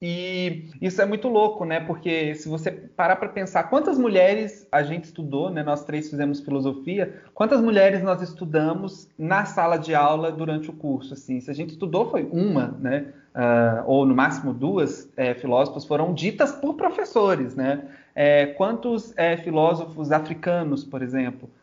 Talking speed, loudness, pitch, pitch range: 165 wpm, -23 LUFS, 160 Hz, 145-190 Hz